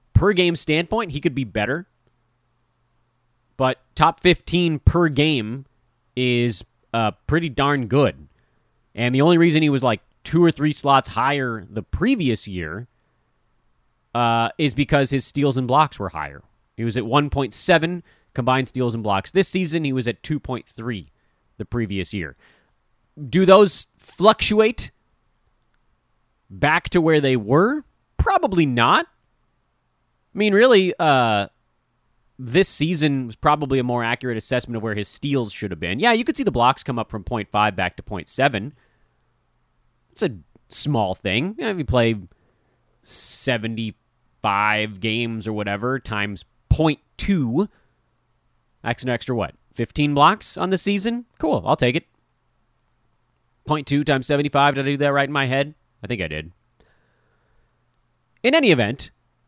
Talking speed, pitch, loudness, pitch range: 145 wpm, 130 Hz, -20 LUFS, 115-150 Hz